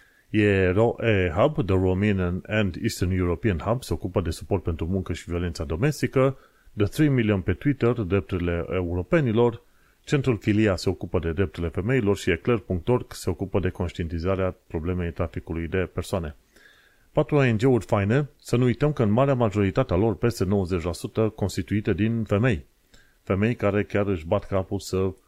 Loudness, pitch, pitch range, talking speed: -25 LUFS, 100 Hz, 95-115 Hz, 150 wpm